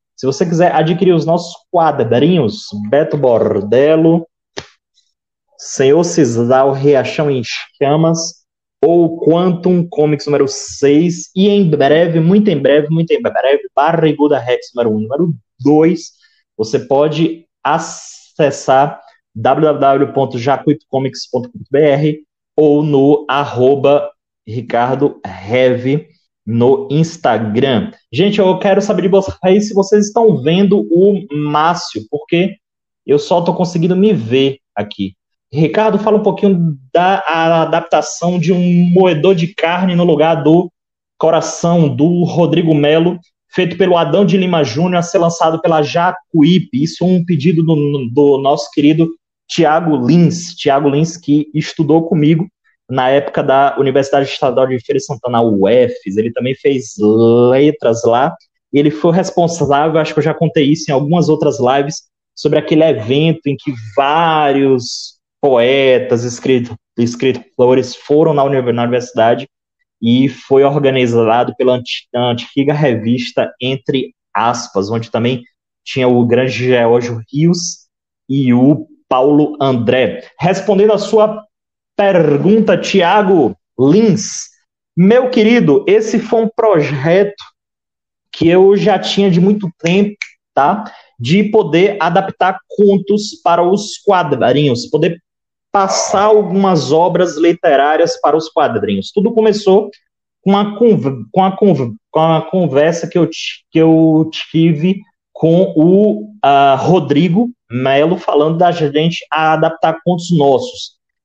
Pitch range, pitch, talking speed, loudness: 135-185 Hz, 160 Hz, 125 wpm, -12 LUFS